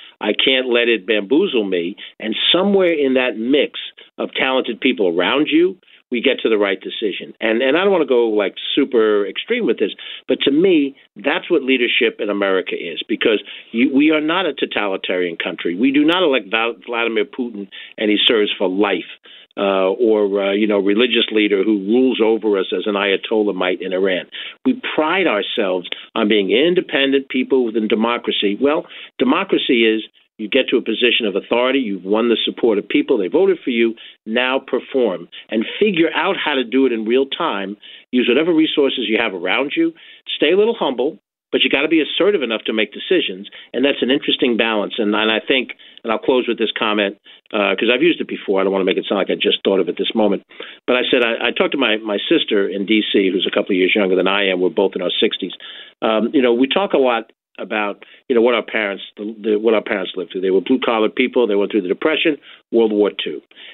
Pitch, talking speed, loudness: 125 Hz, 225 wpm, -17 LUFS